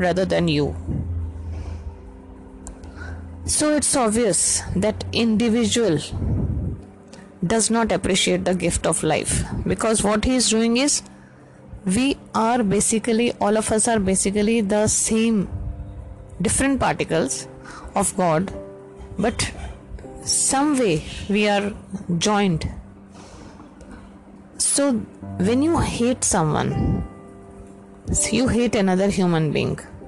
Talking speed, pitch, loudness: 100 wpm, 180 Hz, -20 LUFS